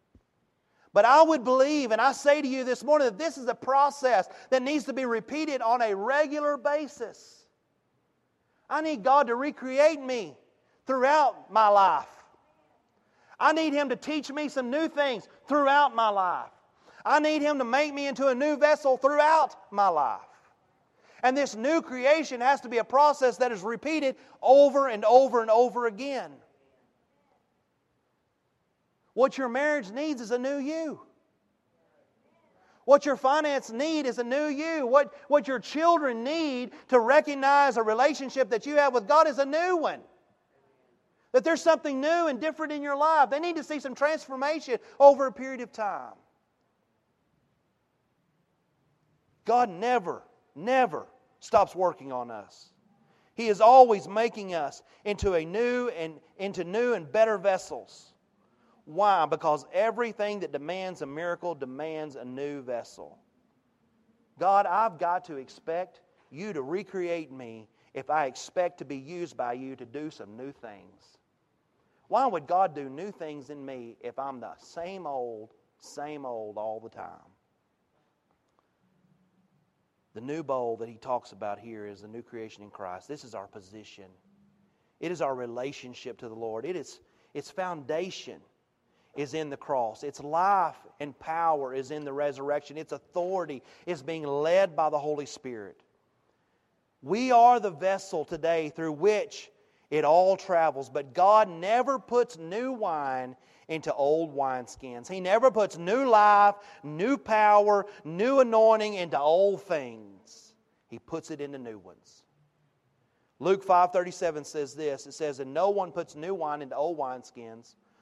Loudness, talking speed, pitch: -26 LUFS, 155 wpm, 205 Hz